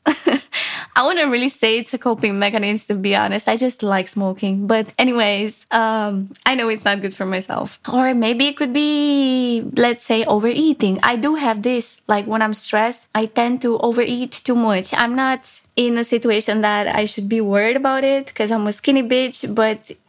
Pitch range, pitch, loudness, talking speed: 210-255 Hz, 230 Hz, -18 LUFS, 195 wpm